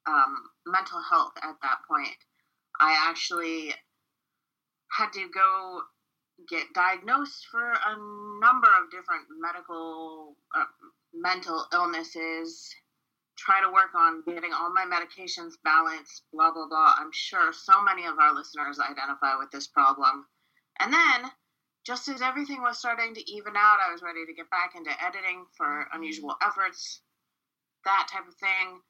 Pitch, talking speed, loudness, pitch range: 185 Hz, 145 wpm, -26 LUFS, 165-225 Hz